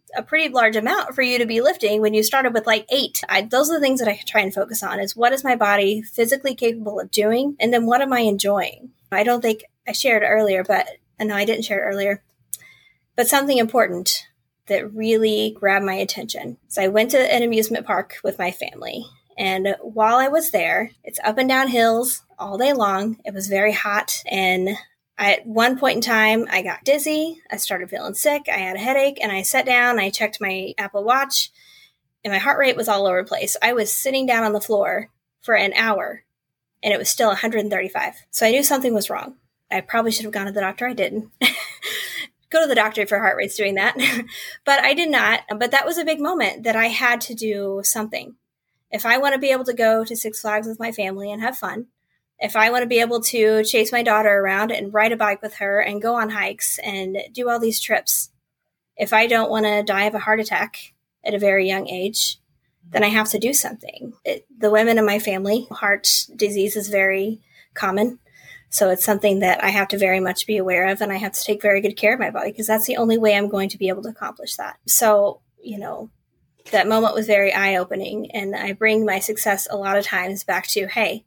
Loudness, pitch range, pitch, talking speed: -19 LUFS, 200-240 Hz, 215 Hz, 235 wpm